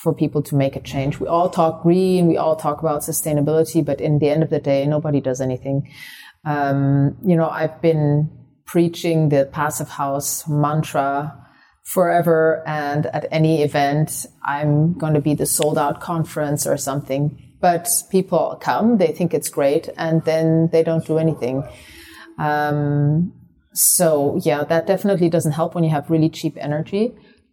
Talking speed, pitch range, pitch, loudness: 165 wpm, 145-165 Hz, 155 Hz, -19 LUFS